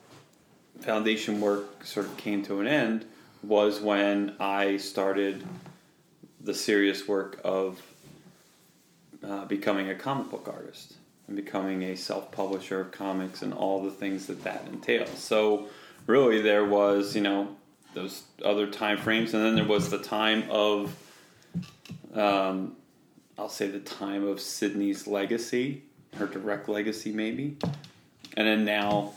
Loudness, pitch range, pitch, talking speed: -28 LUFS, 100-110 Hz, 105 Hz, 140 wpm